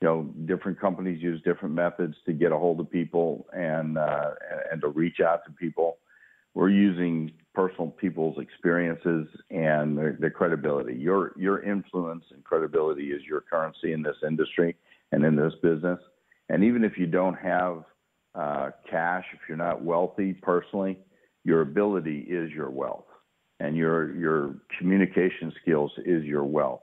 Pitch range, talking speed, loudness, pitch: 80-90 Hz, 160 wpm, -27 LUFS, 85 Hz